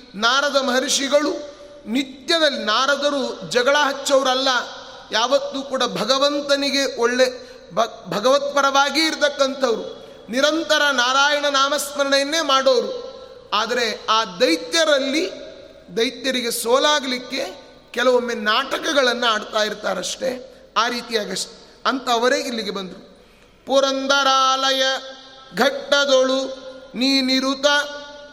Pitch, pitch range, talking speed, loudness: 270 Hz, 250-285 Hz, 70 wpm, -19 LUFS